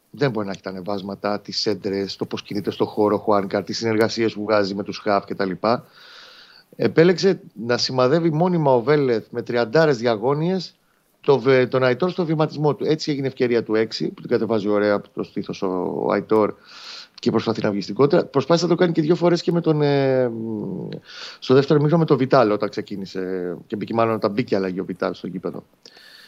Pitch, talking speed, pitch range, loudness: 120 Hz, 195 wpm, 105-155 Hz, -21 LUFS